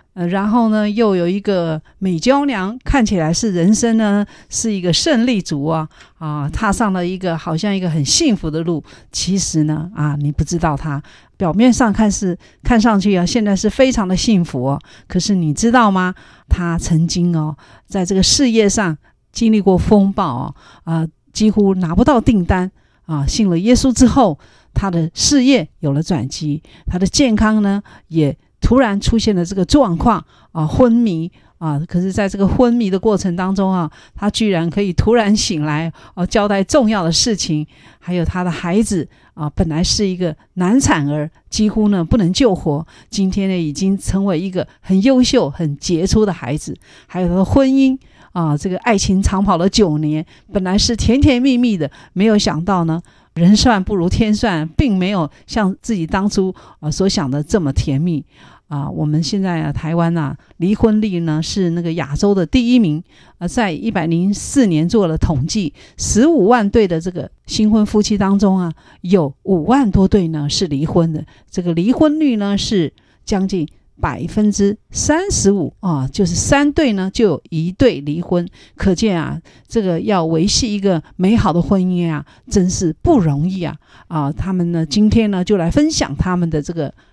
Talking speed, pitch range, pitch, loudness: 260 characters per minute, 160-215 Hz, 185 Hz, -16 LUFS